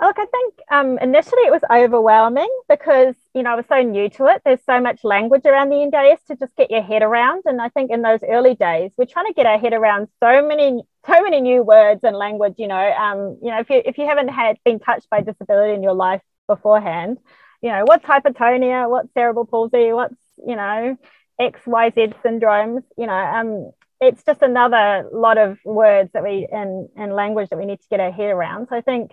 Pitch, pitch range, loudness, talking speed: 240 Hz, 215-280 Hz, -16 LUFS, 225 wpm